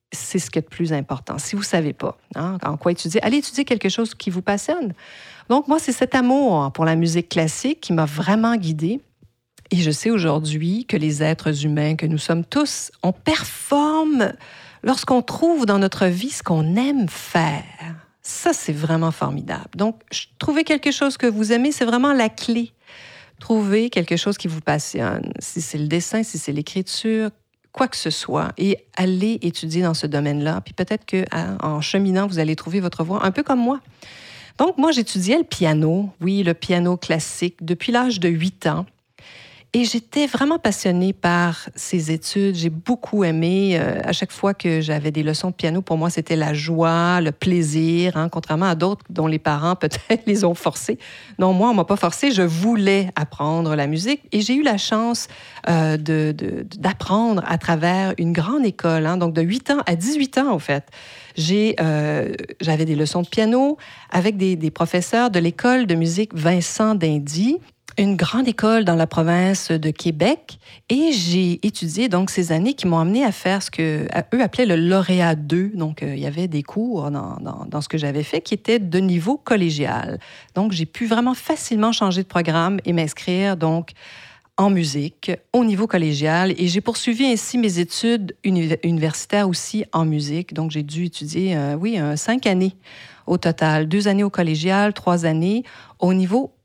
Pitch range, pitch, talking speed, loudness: 165-220 Hz, 180 Hz, 190 wpm, -20 LUFS